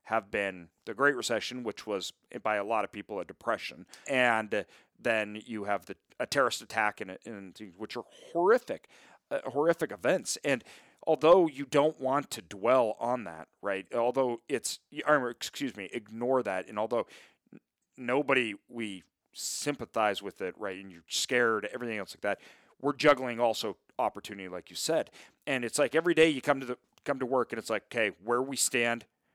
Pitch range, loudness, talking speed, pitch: 100-135 Hz, -31 LUFS, 180 wpm, 120 Hz